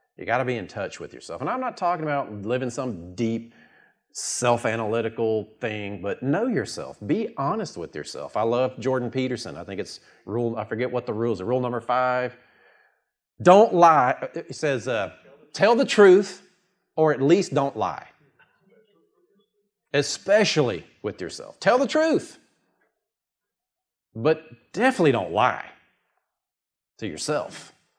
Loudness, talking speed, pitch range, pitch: -23 LUFS, 145 wpm, 115-185 Hz, 130 Hz